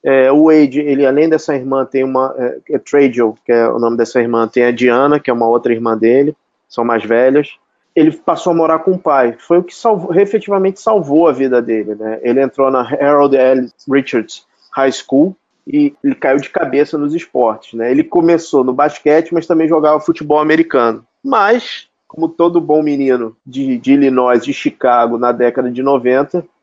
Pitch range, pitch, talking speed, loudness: 125-160 Hz, 140 Hz, 195 wpm, -13 LUFS